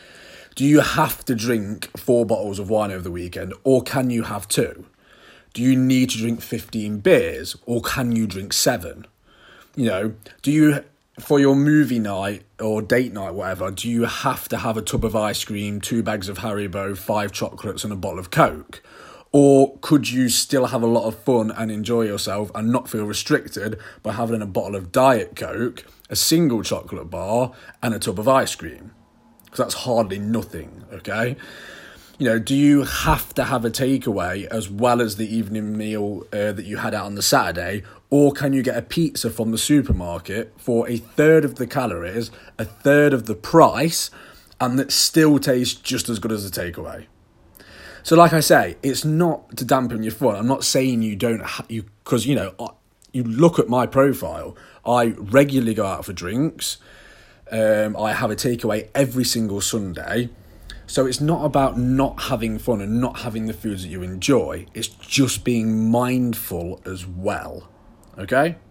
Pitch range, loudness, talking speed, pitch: 105-130 Hz, -20 LUFS, 190 wpm, 115 Hz